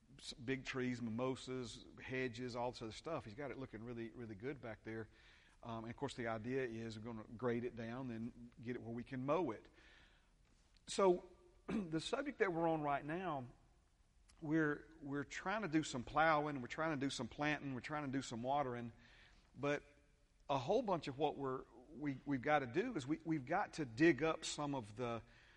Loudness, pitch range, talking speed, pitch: -42 LUFS, 120-150 Hz, 205 wpm, 130 Hz